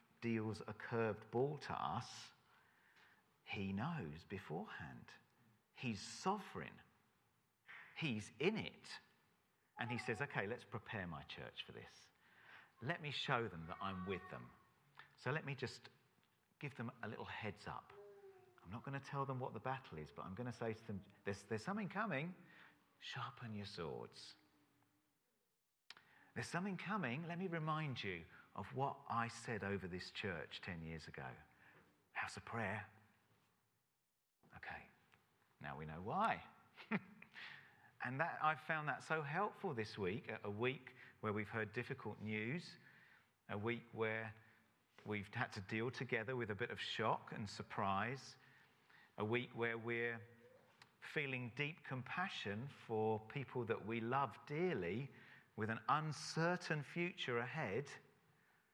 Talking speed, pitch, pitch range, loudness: 145 wpm, 120 Hz, 110-140 Hz, -45 LUFS